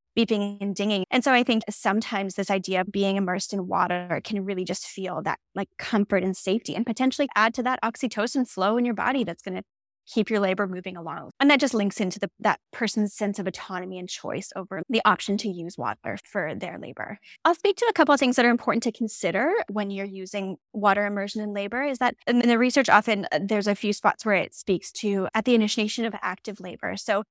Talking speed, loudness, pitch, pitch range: 230 wpm, -25 LUFS, 205 Hz, 195-230 Hz